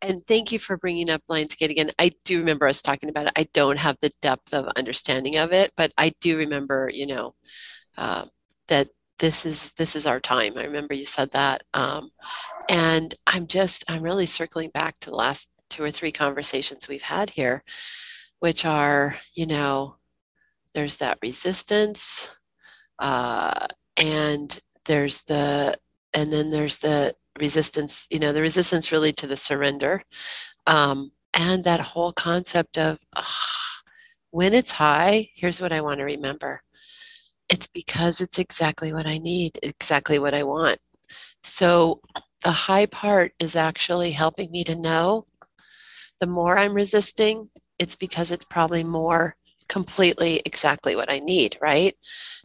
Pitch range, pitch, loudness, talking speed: 150-185 Hz, 160 Hz, -23 LUFS, 155 wpm